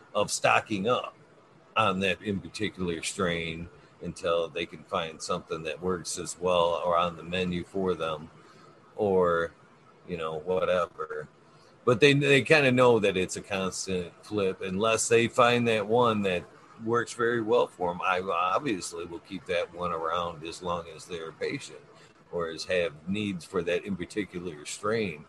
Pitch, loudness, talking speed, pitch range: 100 Hz, -28 LUFS, 165 wpm, 90-125 Hz